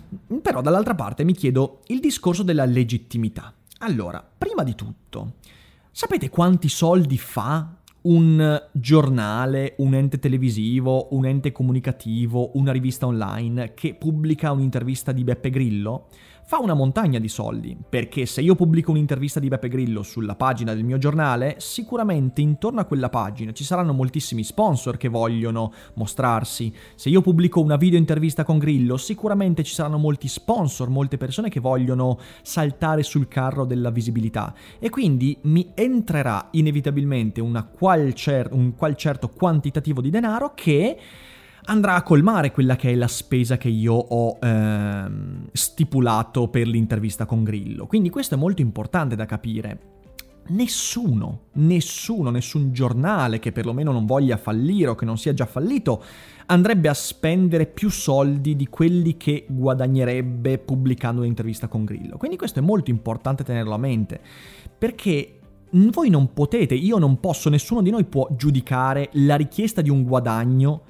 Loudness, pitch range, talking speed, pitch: -21 LUFS, 120-160 Hz, 150 wpm, 135 Hz